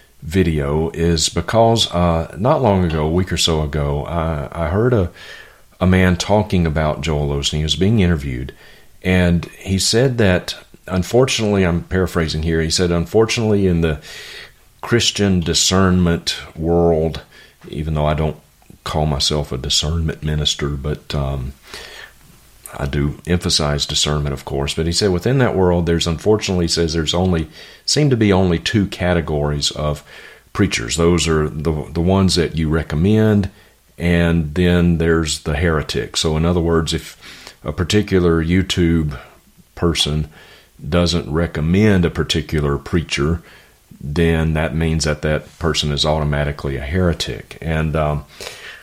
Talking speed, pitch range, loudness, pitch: 145 wpm, 75-90 Hz, -17 LUFS, 85 Hz